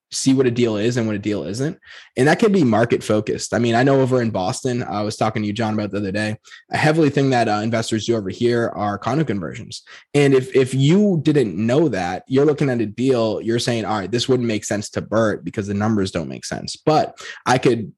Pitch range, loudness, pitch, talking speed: 105-130 Hz, -19 LUFS, 115 Hz, 255 wpm